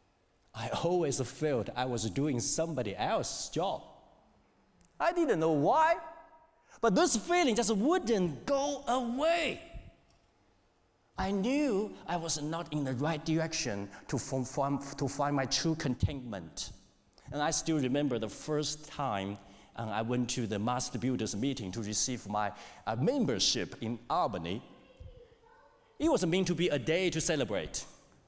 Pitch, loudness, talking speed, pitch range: 150 Hz, -32 LUFS, 135 wpm, 120-200 Hz